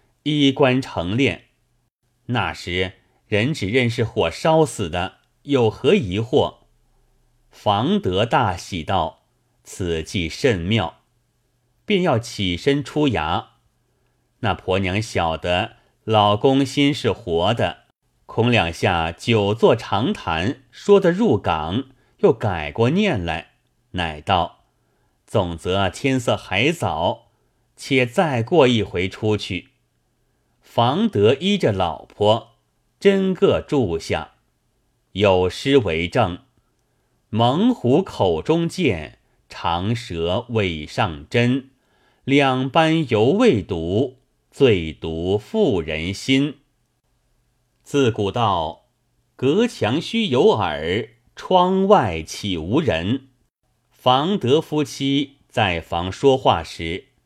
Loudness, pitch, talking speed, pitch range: -20 LUFS, 120 Hz, 135 characters per minute, 95-140 Hz